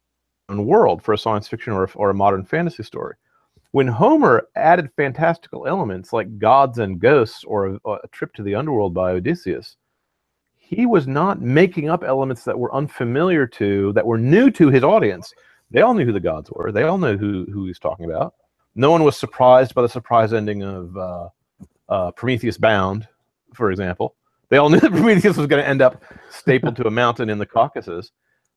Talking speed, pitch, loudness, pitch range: 195 wpm, 115 Hz, -18 LUFS, 100-140 Hz